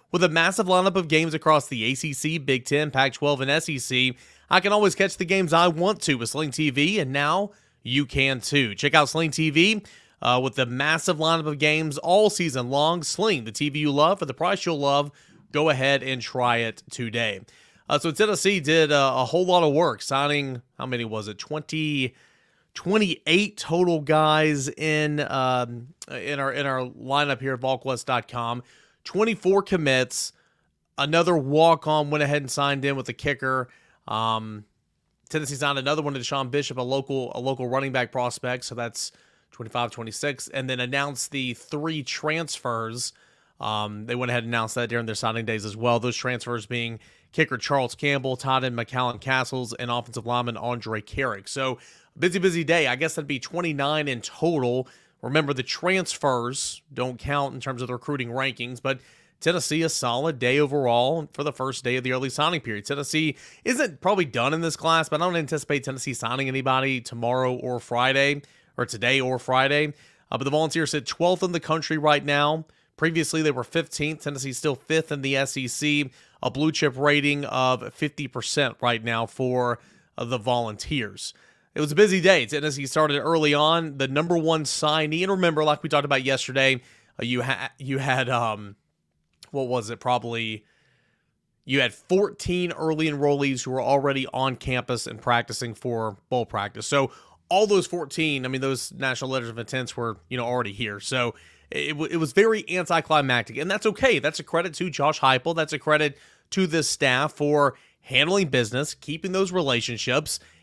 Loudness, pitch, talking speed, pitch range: -24 LUFS, 140 Hz, 180 wpm, 125-155 Hz